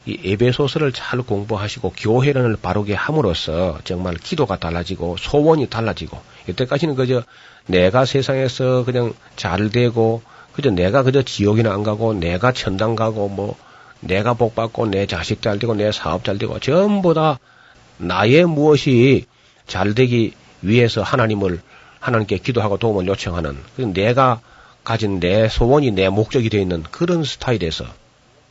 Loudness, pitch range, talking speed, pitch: -18 LUFS, 95-130 Hz, 315 characters per minute, 110 Hz